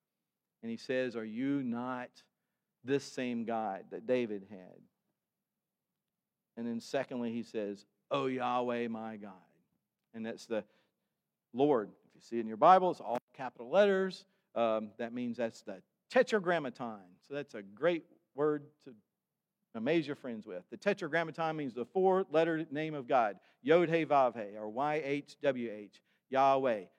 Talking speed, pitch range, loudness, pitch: 150 wpm, 115-160 Hz, -34 LUFS, 130 Hz